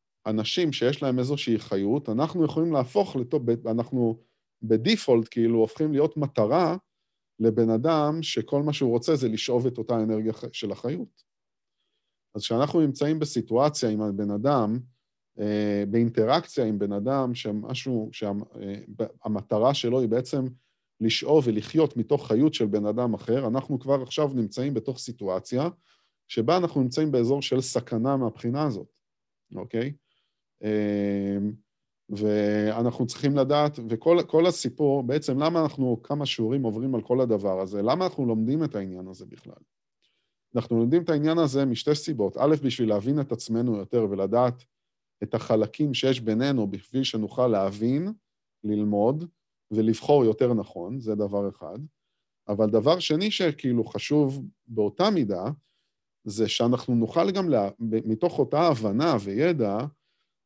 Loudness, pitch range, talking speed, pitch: -26 LUFS, 110-145 Hz, 130 wpm, 120 Hz